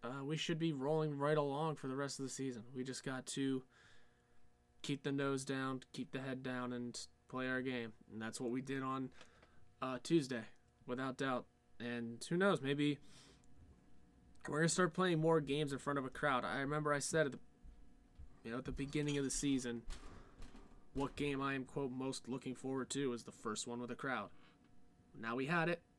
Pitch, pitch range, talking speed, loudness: 130 Hz, 120-145 Hz, 205 wpm, -41 LUFS